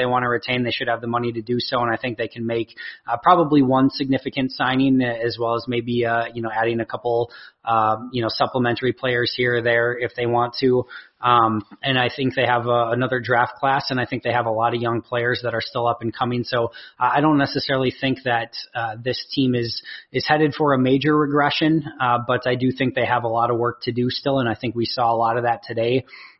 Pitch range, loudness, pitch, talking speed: 115-130 Hz, -21 LUFS, 120 Hz, 255 wpm